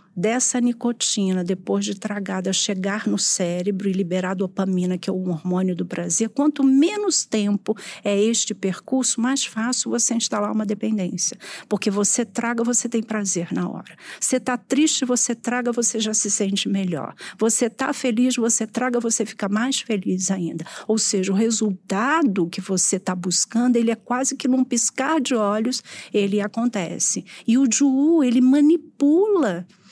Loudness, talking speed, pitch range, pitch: -21 LUFS, 160 wpm, 195-245 Hz, 220 Hz